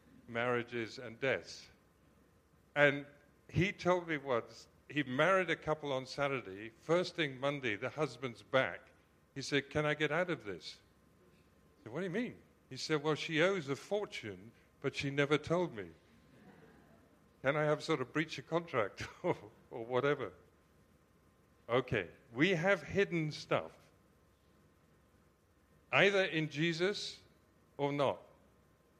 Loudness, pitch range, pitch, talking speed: -36 LUFS, 95-155 Hz, 140 Hz, 140 wpm